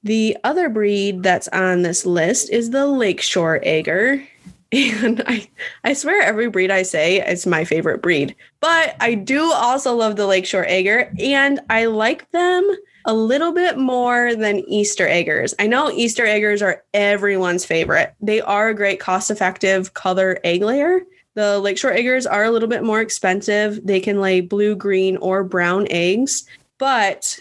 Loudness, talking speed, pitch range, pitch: -17 LUFS, 165 wpm, 190-245 Hz, 210 Hz